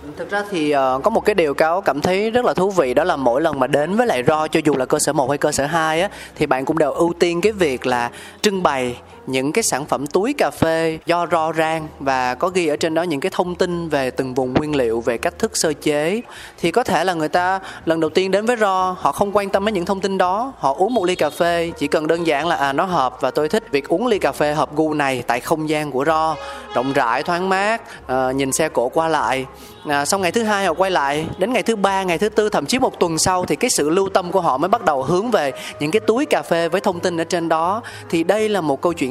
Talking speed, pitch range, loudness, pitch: 285 wpm, 145-190 Hz, -19 LUFS, 165 Hz